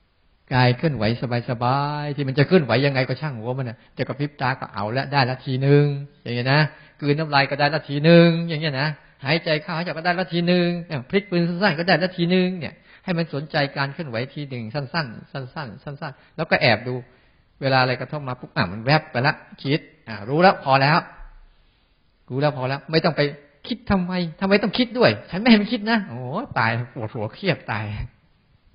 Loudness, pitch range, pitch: -21 LUFS, 130-170 Hz, 145 Hz